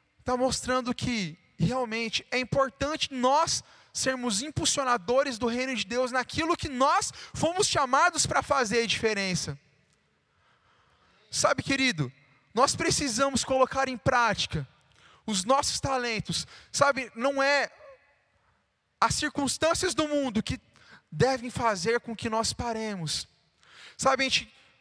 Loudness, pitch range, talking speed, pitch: -27 LUFS, 225-275 Hz, 120 wpm, 255 Hz